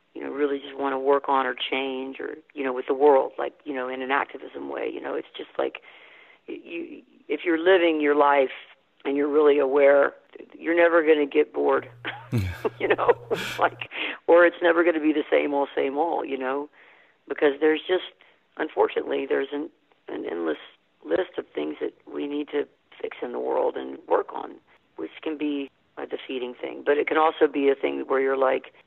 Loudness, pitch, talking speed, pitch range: -24 LUFS, 145 Hz, 205 wpm, 135-175 Hz